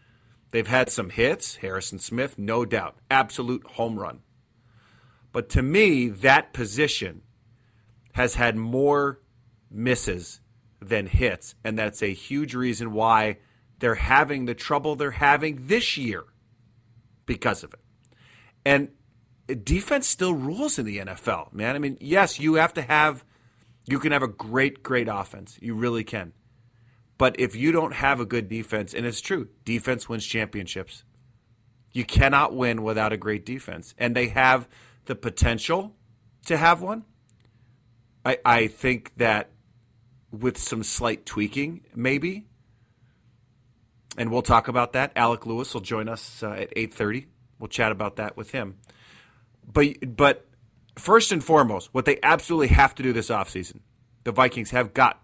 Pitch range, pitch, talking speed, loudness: 115-130 Hz, 120 Hz, 150 wpm, -24 LUFS